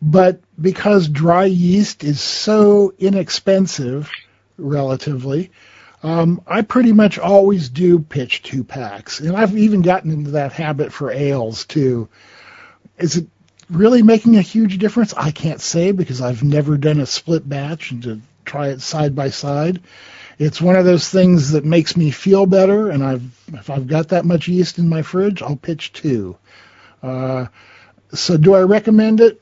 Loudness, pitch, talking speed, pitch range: -15 LUFS, 165 Hz, 165 wpm, 140-190 Hz